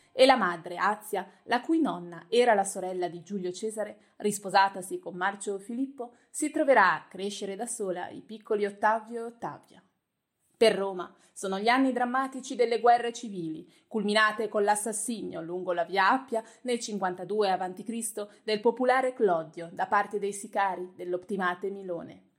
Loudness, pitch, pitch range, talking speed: -28 LUFS, 210 Hz, 185-235 Hz, 150 wpm